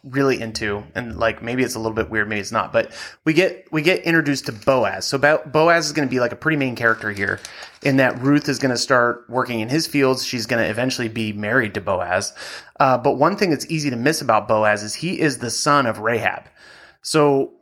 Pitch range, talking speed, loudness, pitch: 115-145 Hz, 240 wpm, -20 LUFS, 130 Hz